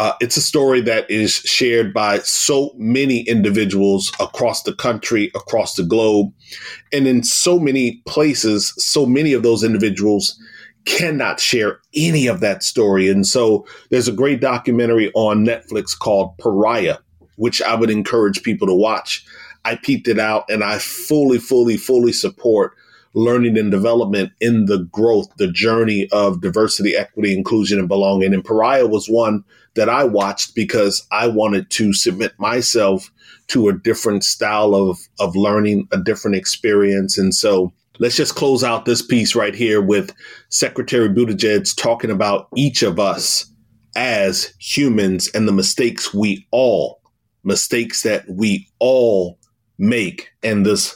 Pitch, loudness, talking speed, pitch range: 110 Hz, -16 LUFS, 150 wpm, 100-120 Hz